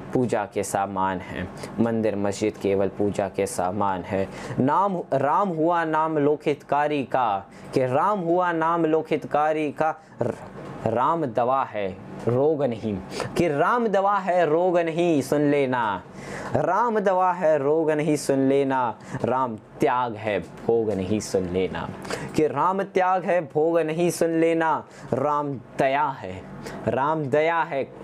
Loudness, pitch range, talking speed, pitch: -24 LUFS, 110-165 Hz, 135 wpm, 150 Hz